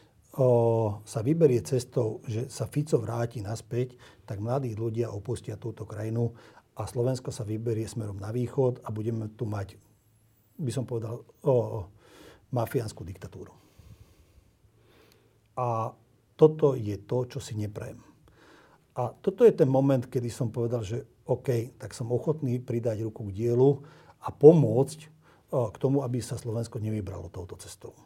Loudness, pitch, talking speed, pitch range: -28 LUFS, 120 Hz, 145 wpm, 110-130 Hz